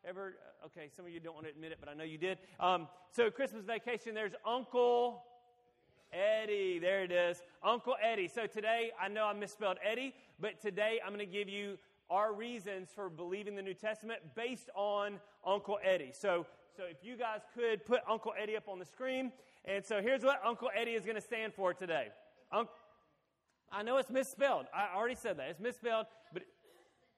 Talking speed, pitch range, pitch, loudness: 195 wpm, 185-235 Hz, 210 Hz, -38 LUFS